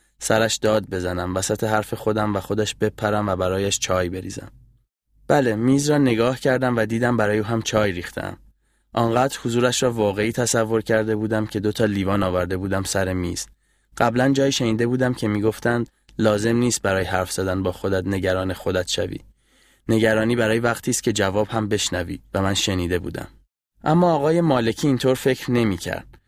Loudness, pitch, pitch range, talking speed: -21 LUFS, 110 Hz, 95-120 Hz, 170 wpm